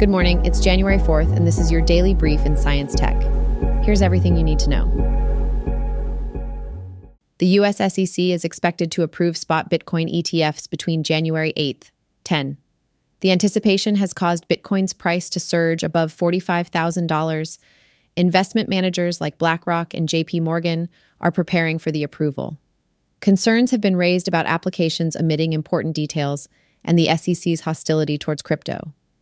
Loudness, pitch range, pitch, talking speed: -20 LUFS, 155-180 Hz, 165 Hz, 145 wpm